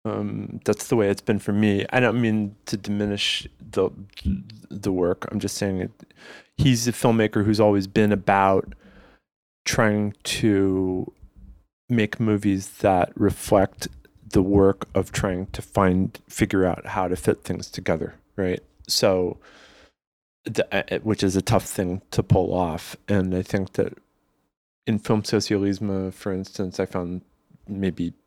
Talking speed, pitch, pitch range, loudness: 145 wpm, 100 Hz, 95-110 Hz, -23 LUFS